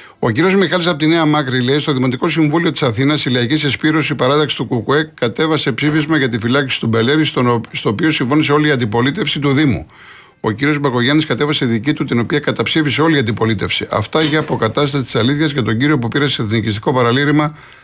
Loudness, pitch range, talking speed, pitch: -15 LUFS, 125-155 Hz, 200 wpm, 145 Hz